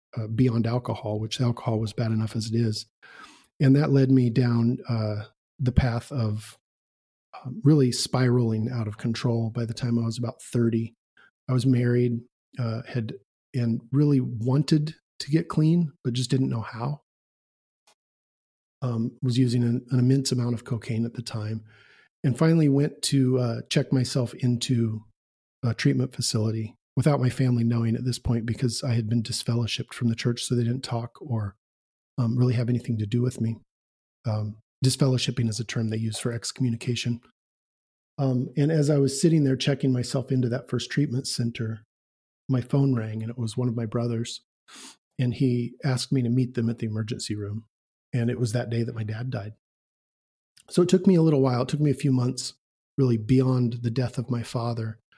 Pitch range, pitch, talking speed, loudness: 115-130 Hz, 120 Hz, 190 wpm, -26 LUFS